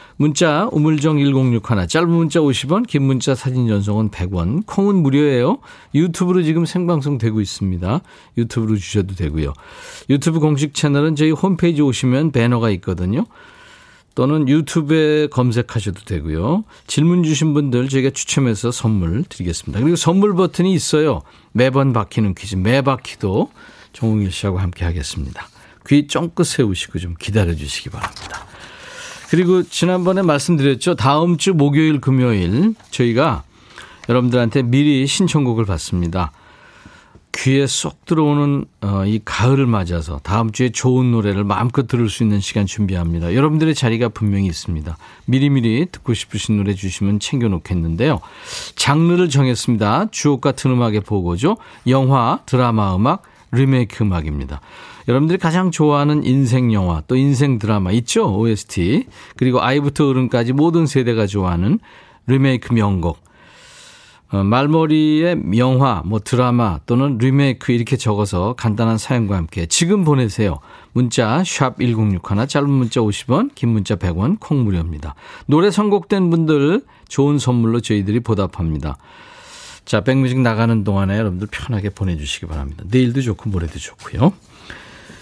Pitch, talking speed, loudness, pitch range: 125 Hz, 335 characters per minute, -17 LUFS, 105-145 Hz